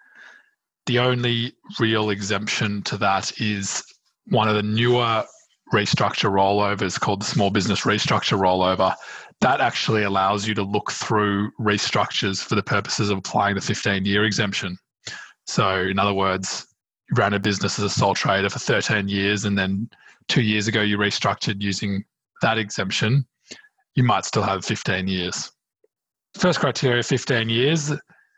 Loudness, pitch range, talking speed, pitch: -22 LUFS, 100-115 Hz, 150 wpm, 105 Hz